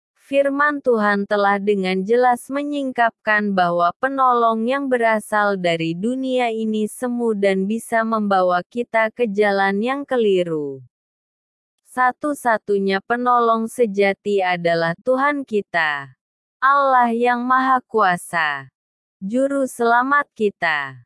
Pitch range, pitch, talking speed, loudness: 195-250 Hz, 225 Hz, 100 wpm, -19 LUFS